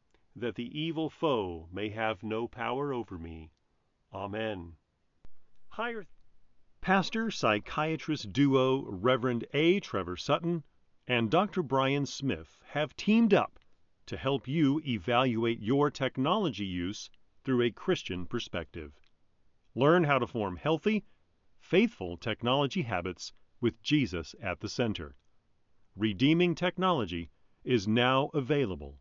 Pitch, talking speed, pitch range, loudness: 120 Hz, 110 wpm, 100-150 Hz, -30 LUFS